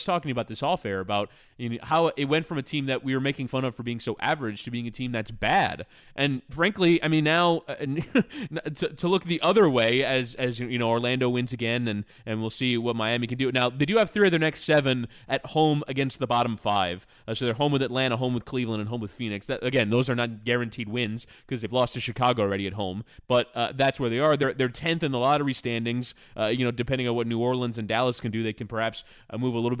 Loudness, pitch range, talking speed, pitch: -26 LUFS, 115-140 Hz, 265 wpm, 125 Hz